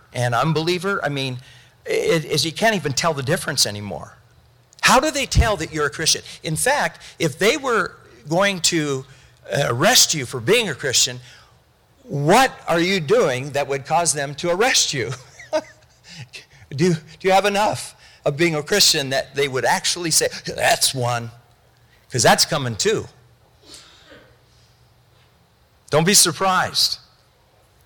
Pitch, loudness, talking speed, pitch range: 155 Hz, -19 LUFS, 145 wpm, 135-180 Hz